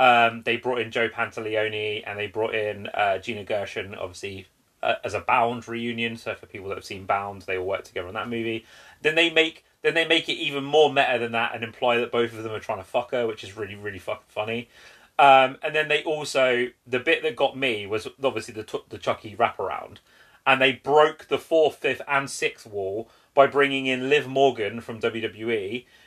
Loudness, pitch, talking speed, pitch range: -24 LUFS, 120 Hz, 220 wpm, 110-140 Hz